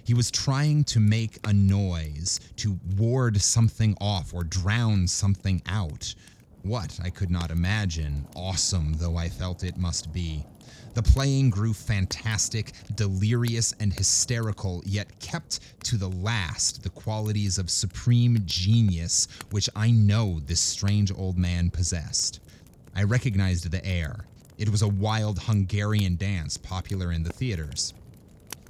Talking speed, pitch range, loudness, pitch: 140 wpm, 90-110 Hz, -26 LUFS, 100 Hz